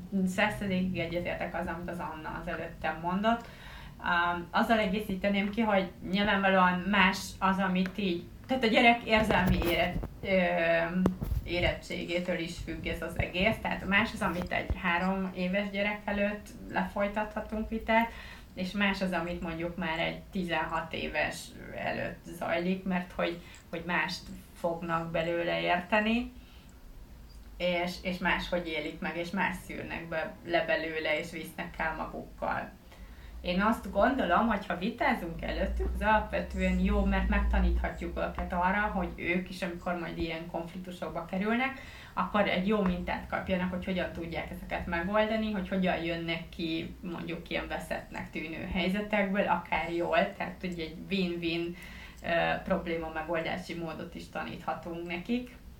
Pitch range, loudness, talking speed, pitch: 170-200 Hz, -31 LUFS, 135 wpm, 180 Hz